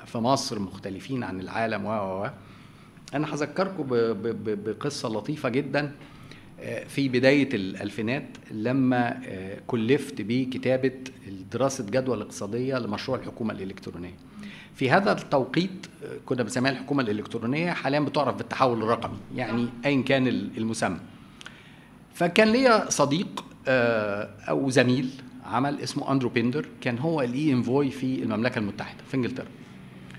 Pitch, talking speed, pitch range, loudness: 130 Hz, 110 wpm, 110-140 Hz, -26 LUFS